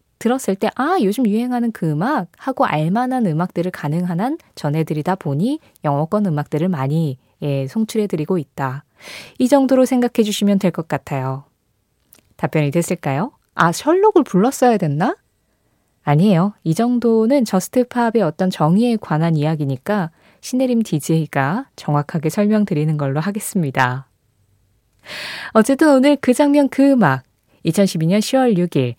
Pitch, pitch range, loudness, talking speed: 185 Hz, 150-235 Hz, -18 LUFS, 300 characters per minute